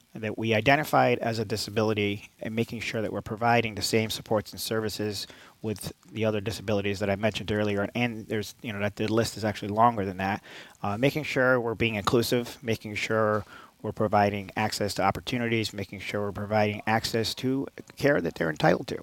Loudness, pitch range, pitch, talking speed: -27 LUFS, 105-115 Hz, 110 Hz, 190 wpm